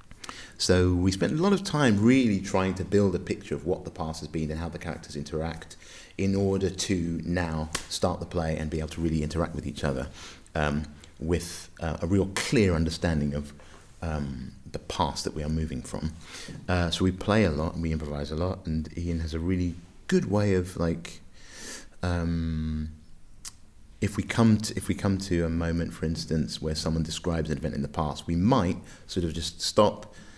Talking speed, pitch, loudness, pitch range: 205 wpm, 85 Hz, -28 LUFS, 80-95 Hz